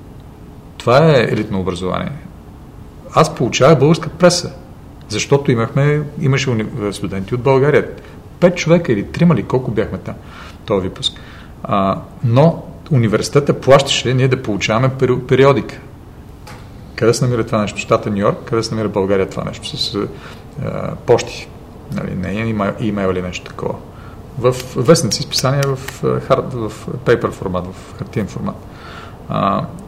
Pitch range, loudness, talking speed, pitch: 100-140 Hz, -16 LUFS, 135 wpm, 120 Hz